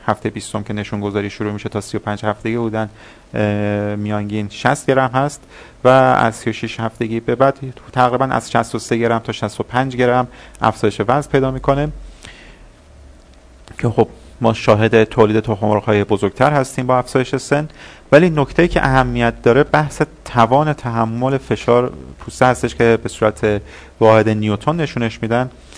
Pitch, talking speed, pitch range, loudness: 115 Hz, 145 wpm, 105-130 Hz, -16 LUFS